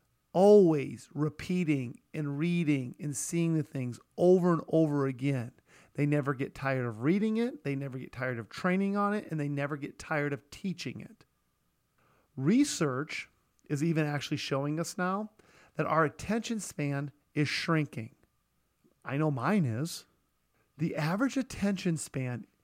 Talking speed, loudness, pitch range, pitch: 150 wpm, -31 LUFS, 140-175 Hz, 150 Hz